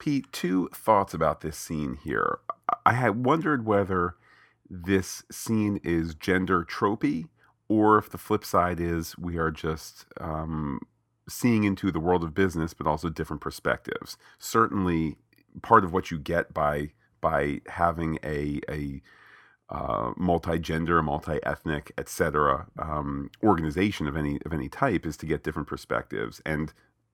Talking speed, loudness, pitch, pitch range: 145 wpm, -27 LUFS, 85 Hz, 75-95 Hz